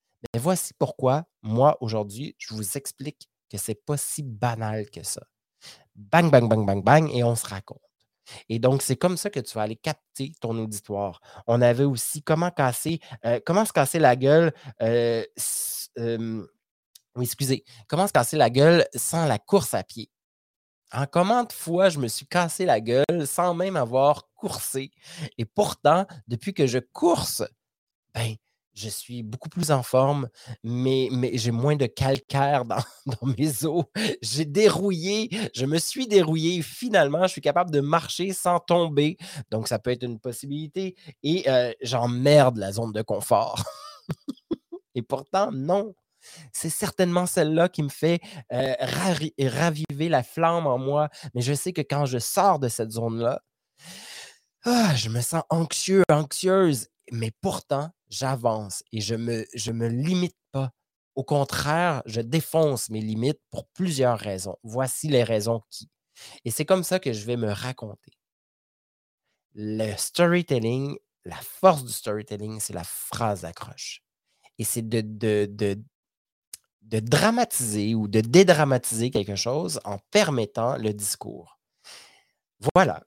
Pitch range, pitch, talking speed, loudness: 115-165 Hz, 135 Hz, 155 wpm, -24 LUFS